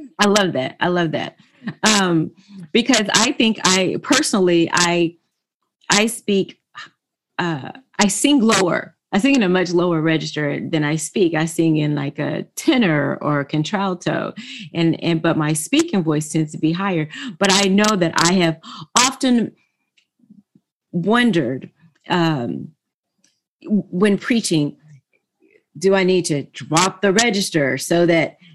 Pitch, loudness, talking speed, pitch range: 180 Hz, -18 LUFS, 140 wpm, 160-210 Hz